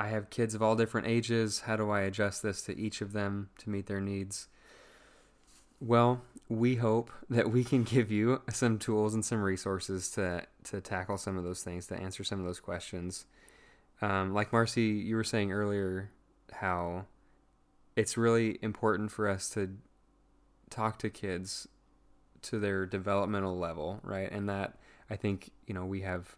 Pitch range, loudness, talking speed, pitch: 95-110 Hz, -33 LUFS, 175 wpm, 100 Hz